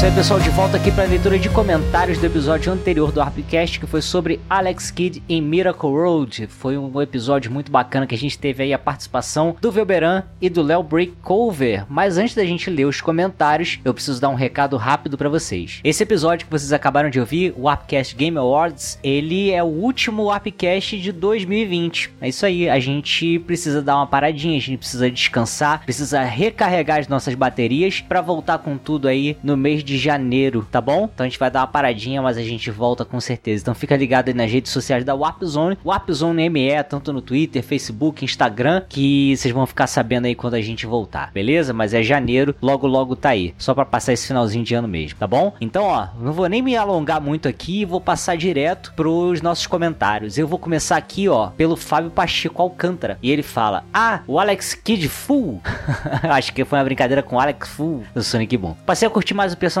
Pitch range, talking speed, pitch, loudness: 130-170 Hz, 215 wpm, 145 Hz, -19 LUFS